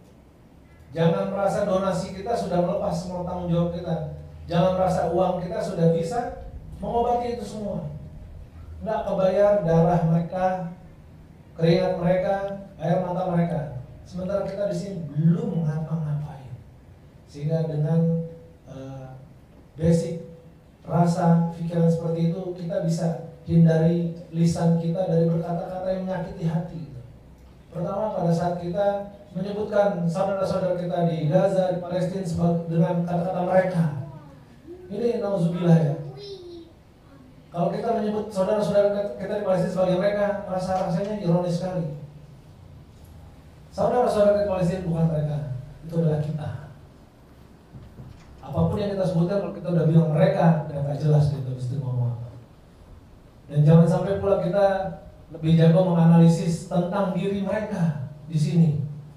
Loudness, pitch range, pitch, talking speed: -24 LUFS, 155-190 Hz, 170 Hz, 120 wpm